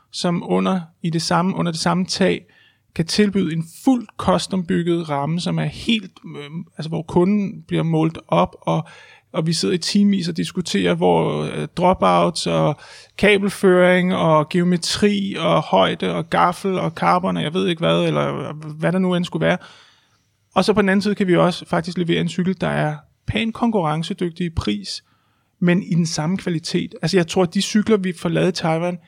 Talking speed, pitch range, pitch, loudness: 190 wpm, 160-190 Hz, 175 Hz, -19 LUFS